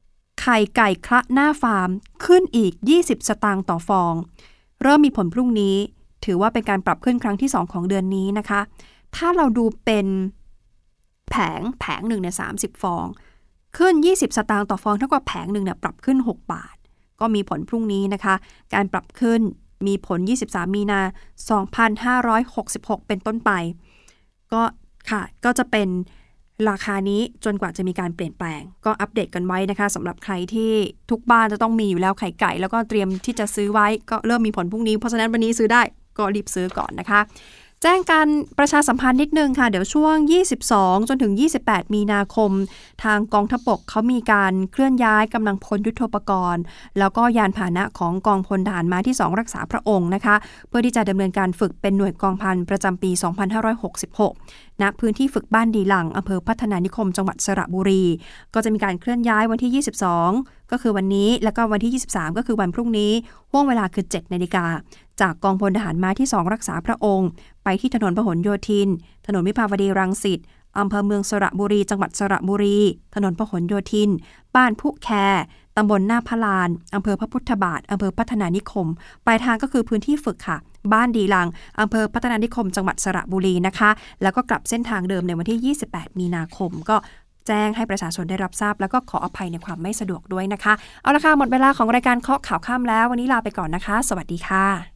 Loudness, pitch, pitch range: -20 LUFS, 210 Hz, 190-230 Hz